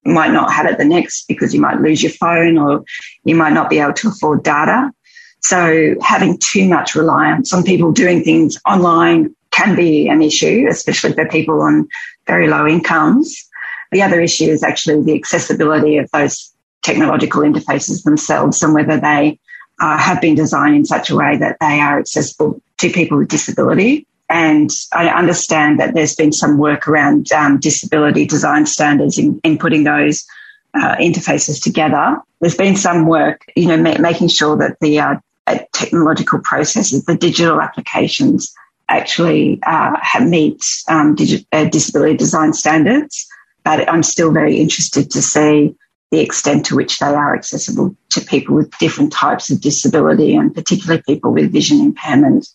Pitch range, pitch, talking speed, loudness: 150-185 Hz, 160 Hz, 170 wpm, -13 LUFS